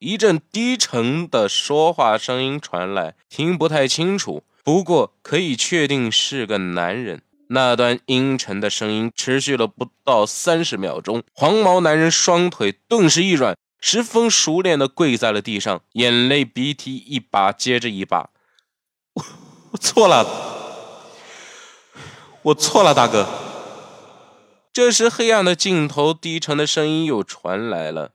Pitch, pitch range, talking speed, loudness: 145 Hz, 120-175 Hz, 205 characters per minute, -18 LUFS